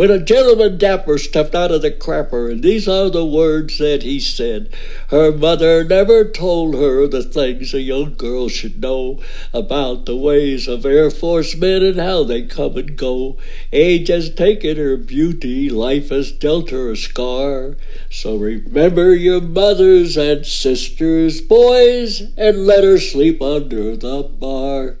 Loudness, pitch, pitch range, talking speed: -15 LUFS, 150 Hz, 135-175 Hz, 160 wpm